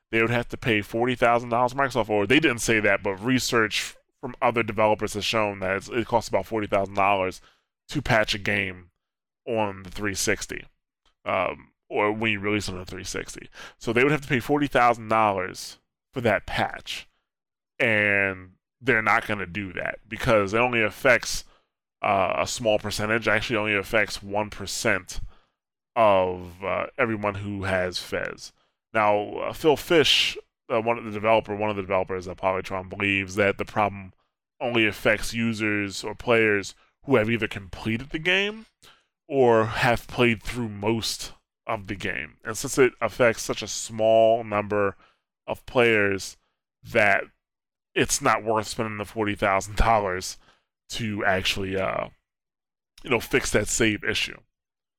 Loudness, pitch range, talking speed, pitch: -24 LUFS, 100-115 Hz, 155 wpm, 105 Hz